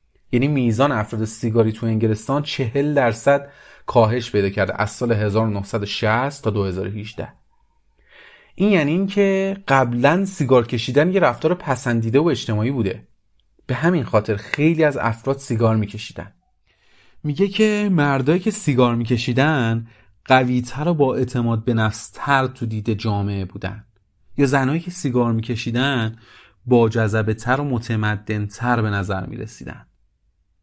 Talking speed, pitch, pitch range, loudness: 130 wpm, 120 Hz, 110-140 Hz, -20 LUFS